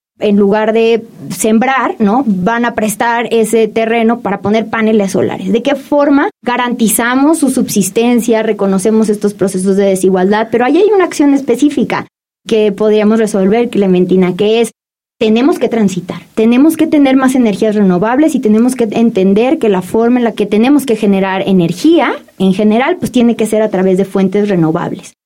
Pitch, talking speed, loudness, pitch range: 220 Hz, 170 wpm, -11 LUFS, 200-240 Hz